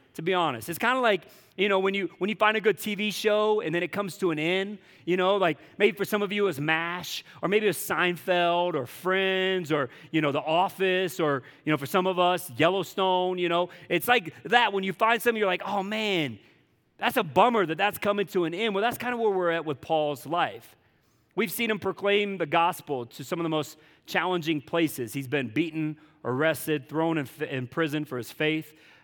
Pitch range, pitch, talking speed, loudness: 155-200 Hz, 180 Hz, 230 wpm, -26 LUFS